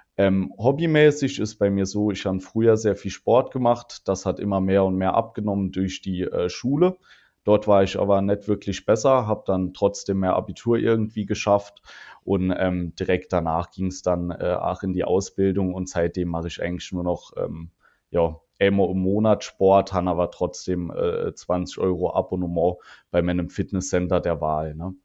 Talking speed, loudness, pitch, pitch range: 180 wpm, -23 LUFS, 95 Hz, 90-105 Hz